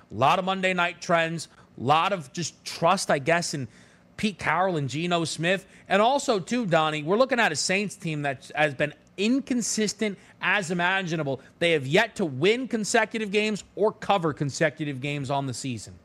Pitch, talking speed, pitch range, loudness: 175 Hz, 185 wpm, 150-210 Hz, -25 LUFS